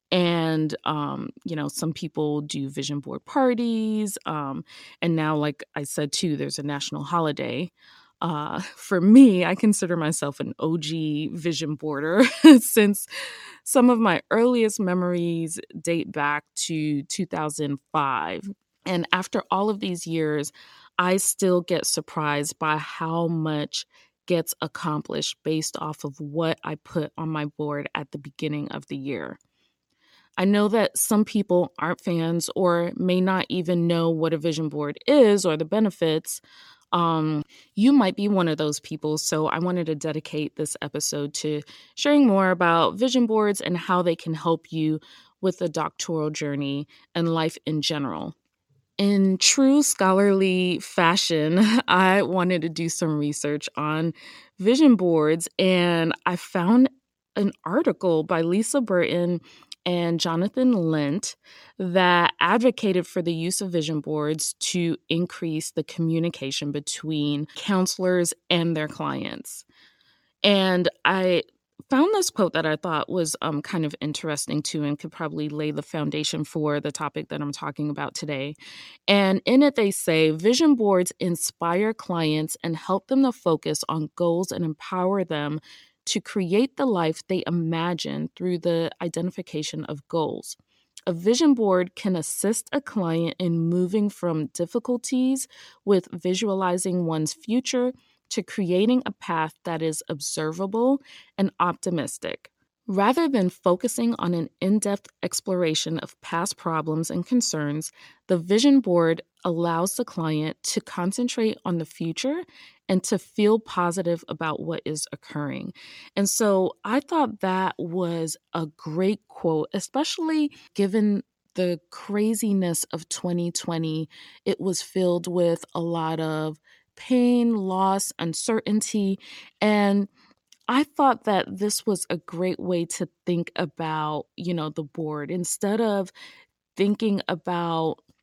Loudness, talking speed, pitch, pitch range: -24 LUFS, 140 wpm, 175 Hz, 155-200 Hz